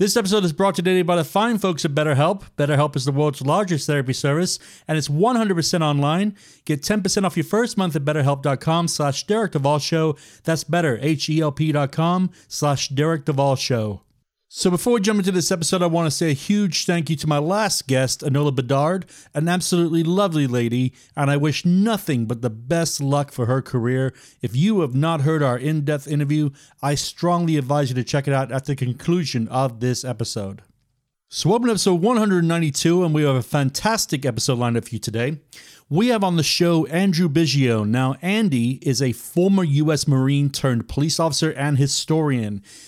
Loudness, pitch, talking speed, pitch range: -20 LUFS, 150 Hz, 180 wpm, 135-175 Hz